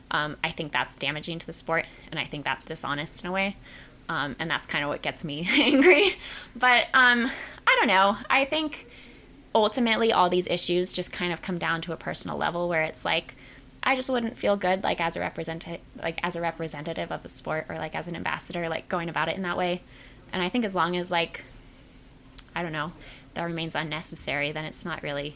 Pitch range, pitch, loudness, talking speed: 155-190 Hz, 170 Hz, -26 LUFS, 220 wpm